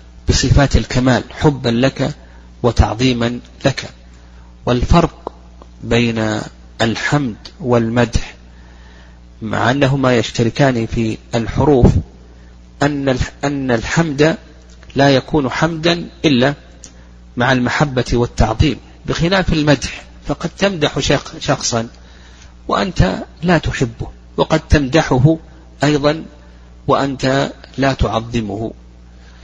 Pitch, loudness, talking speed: 120 Hz, -16 LUFS, 75 wpm